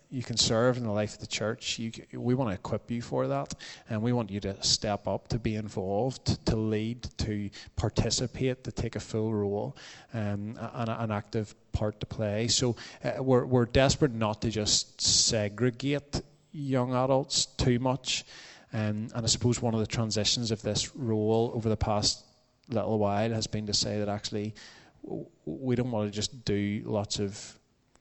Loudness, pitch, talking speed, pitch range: -29 LUFS, 115 Hz, 185 wpm, 105-125 Hz